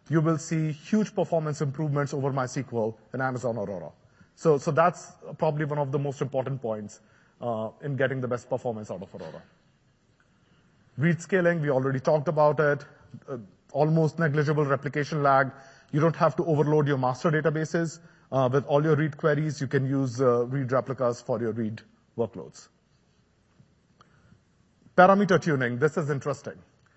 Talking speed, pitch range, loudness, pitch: 160 wpm, 130-155 Hz, -26 LUFS, 145 Hz